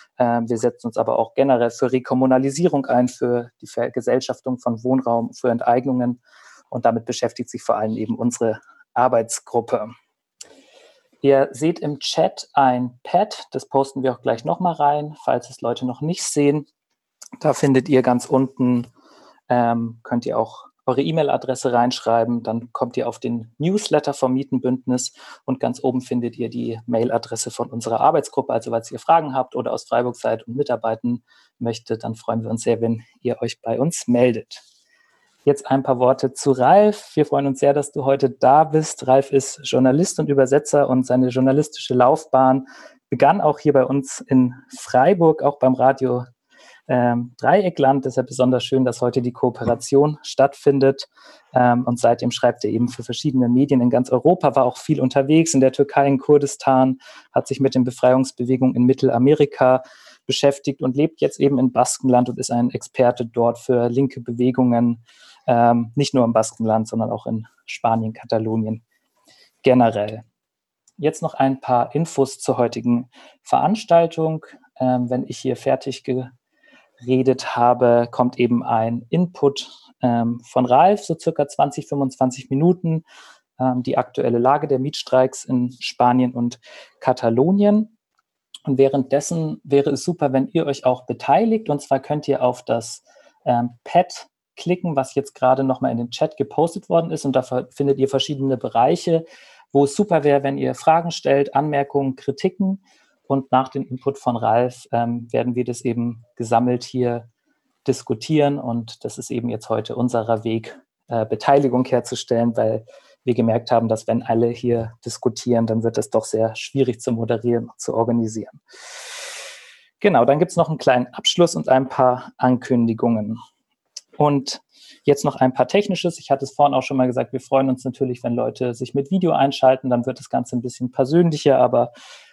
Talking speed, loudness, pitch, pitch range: 165 wpm, -20 LUFS, 130 Hz, 120-140 Hz